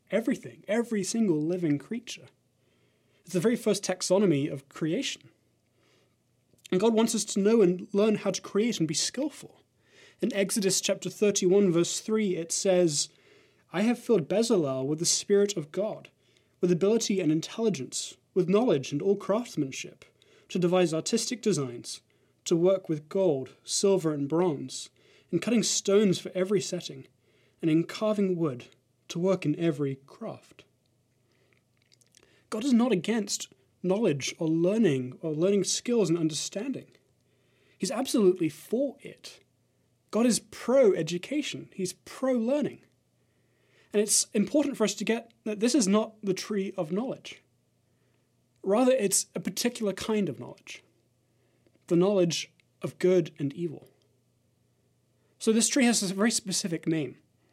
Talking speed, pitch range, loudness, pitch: 145 wpm, 155-215 Hz, -27 LUFS, 185 Hz